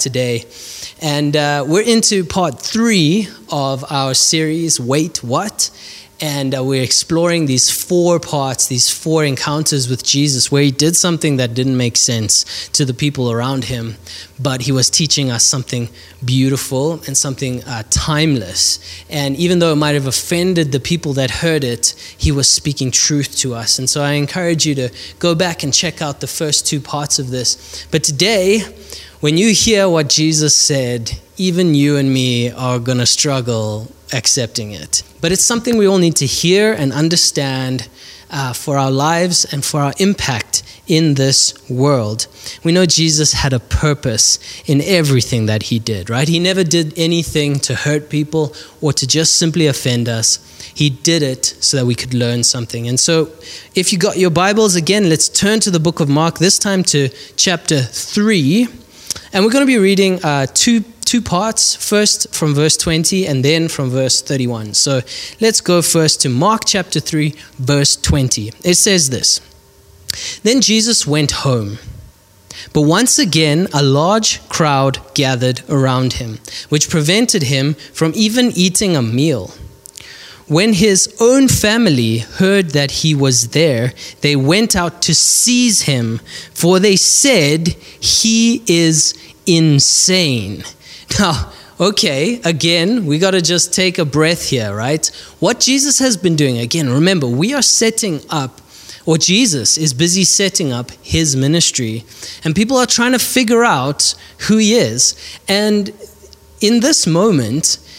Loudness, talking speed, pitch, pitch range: -13 LUFS, 165 wpm, 150 Hz, 130-175 Hz